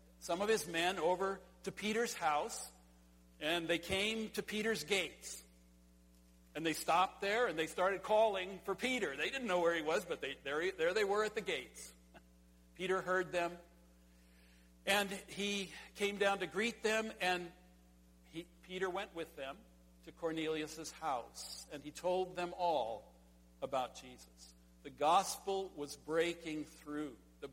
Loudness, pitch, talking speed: -38 LUFS, 170 Hz, 155 wpm